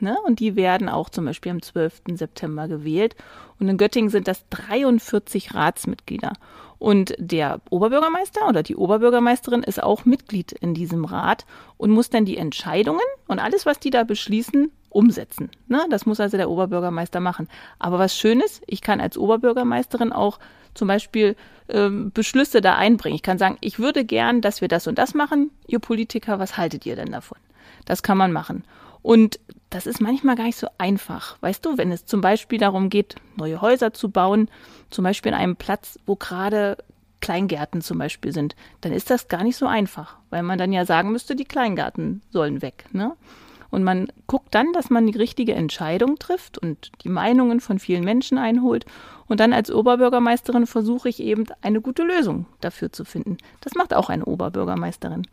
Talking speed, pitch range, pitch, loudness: 180 wpm, 185-245 Hz, 215 Hz, -21 LUFS